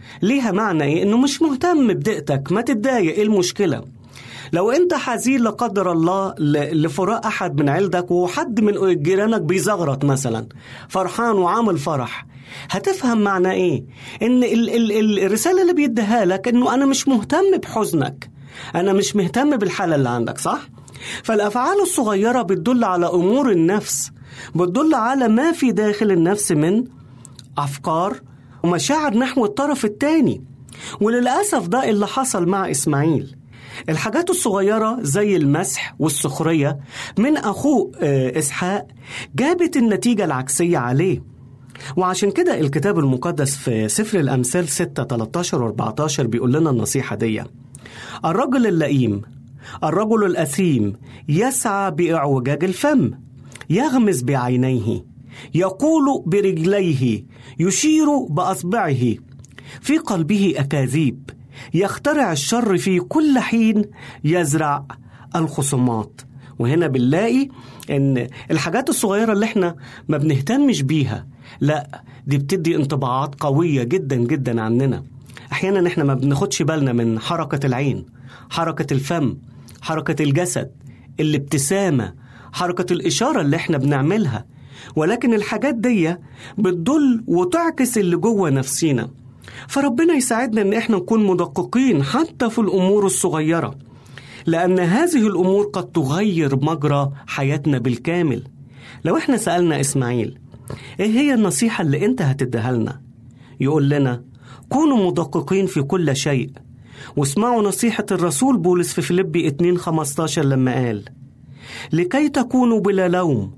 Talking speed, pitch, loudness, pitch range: 115 wpm, 170 Hz, -19 LUFS, 135-210 Hz